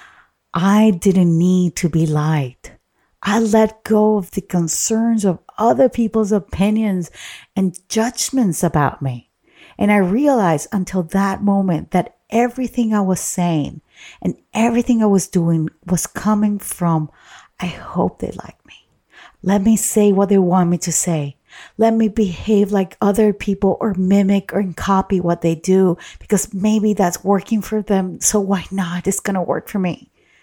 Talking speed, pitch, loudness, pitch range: 160 wpm, 195 Hz, -17 LUFS, 180-215 Hz